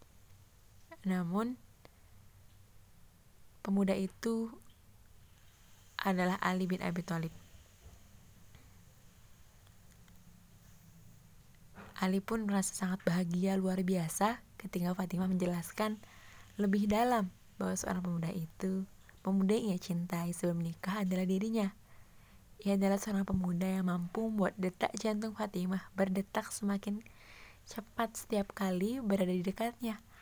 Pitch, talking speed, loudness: 185 Hz, 100 wpm, -35 LUFS